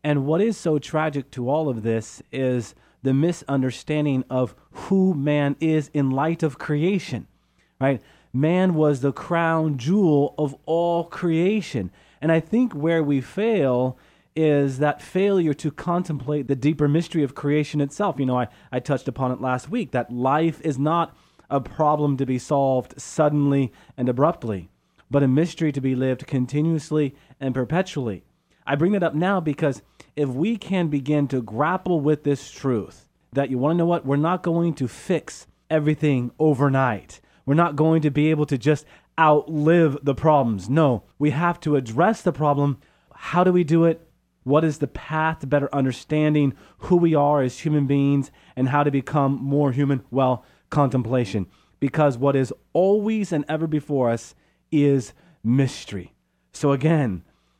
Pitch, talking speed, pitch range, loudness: 145 Hz, 165 wpm, 135-160 Hz, -22 LUFS